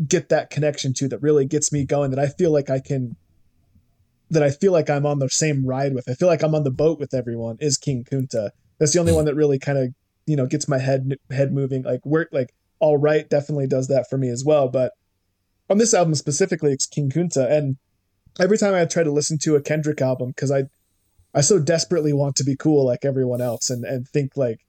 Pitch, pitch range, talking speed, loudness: 140 Hz, 130-150 Hz, 240 wpm, -21 LUFS